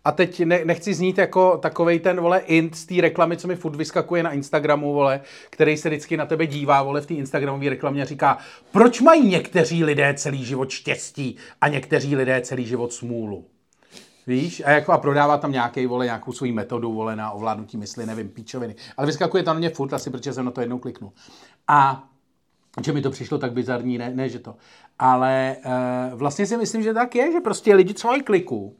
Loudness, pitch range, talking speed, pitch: -21 LUFS, 125-170 Hz, 205 wpm, 145 Hz